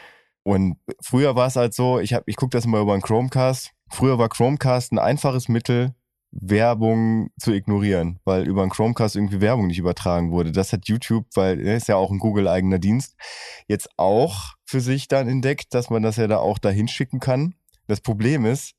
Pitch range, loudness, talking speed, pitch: 100-125 Hz, -21 LUFS, 200 wpm, 115 Hz